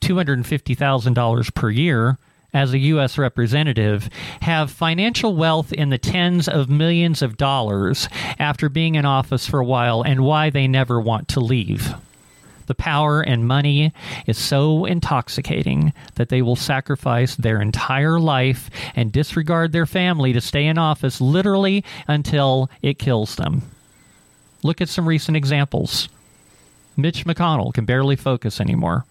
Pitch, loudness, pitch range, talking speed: 140 Hz, -19 LUFS, 125-155 Hz, 140 wpm